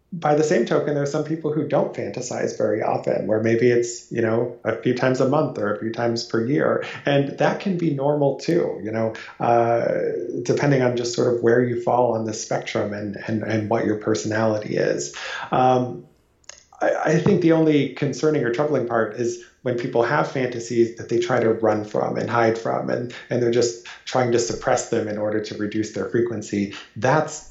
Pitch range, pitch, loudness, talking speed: 110-145 Hz, 120 Hz, -22 LUFS, 205 wpm